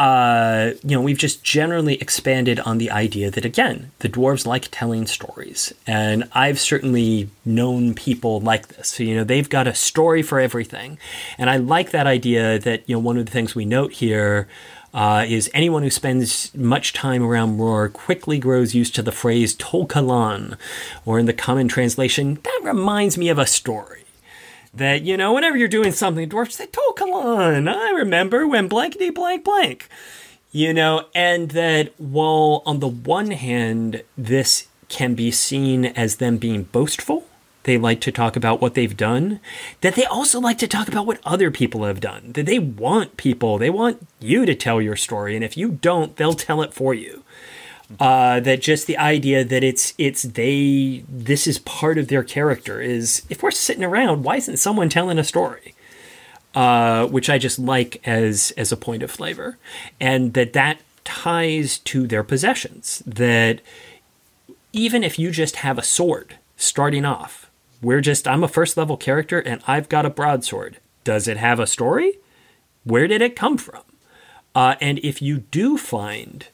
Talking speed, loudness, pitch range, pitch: 185 wpm, -19 LUFS, 120-160 Hz, 135 Hz